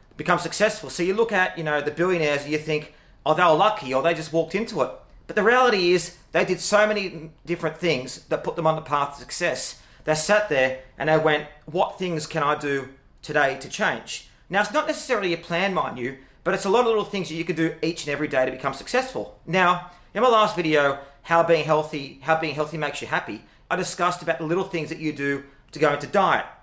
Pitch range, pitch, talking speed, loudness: 145-180 Hz, 160 Hz, 245 wpm, -23 LUFS